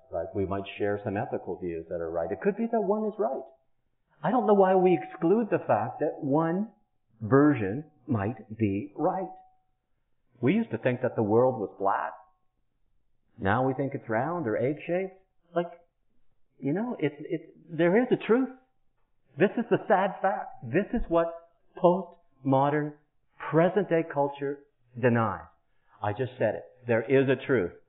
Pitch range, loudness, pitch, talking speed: 120-185 Hz, -28 LUFS, 150 Hz, 165 wpm